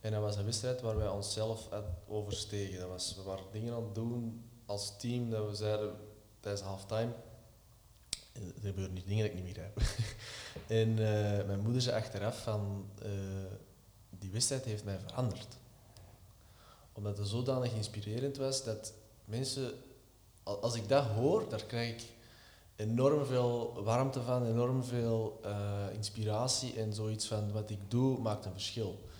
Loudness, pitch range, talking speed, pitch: -37 LUFS, 100-115 Hz, 155 wpm, 110 Hz